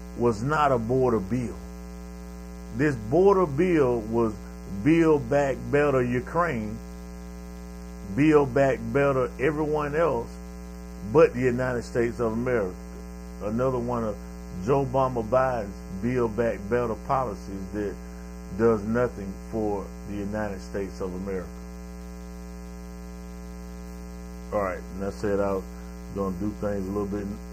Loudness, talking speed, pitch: -26 LUFS, 120 wpm, 100 Hz